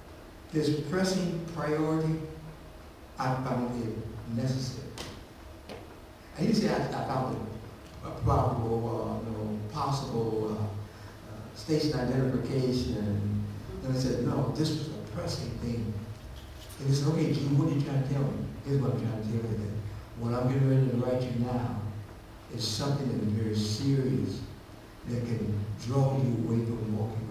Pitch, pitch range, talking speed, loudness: 115 Hz, 105-135 Hz, 170 wpm, -31 LUFS